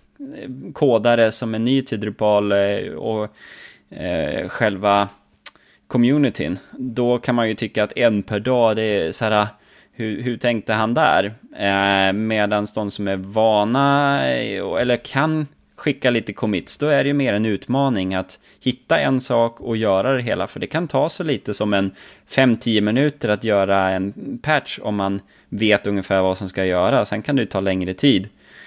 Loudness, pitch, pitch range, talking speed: -20 LUFS, 110 Hz, 100-120 Hz, 170 wpm